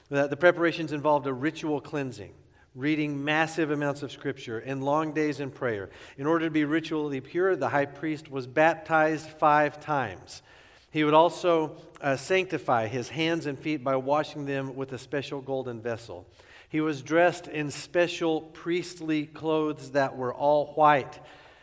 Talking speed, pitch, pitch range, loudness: 160 wpm, 150 Hz, 140-160 Hz, -27 LUFS